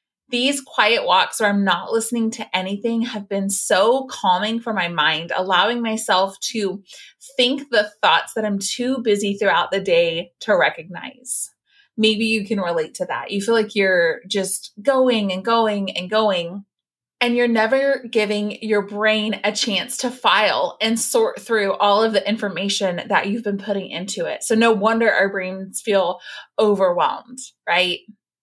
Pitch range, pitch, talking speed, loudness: 195-230 Hz, 210 Hz, 165 wpm, -19 LUFS